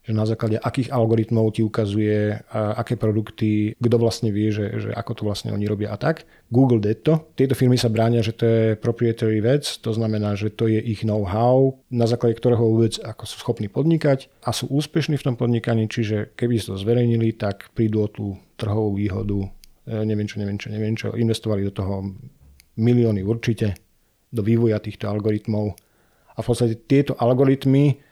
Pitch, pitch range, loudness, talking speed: 115 Hz, 105-120 Hz, -22 LUFS, 185 wpm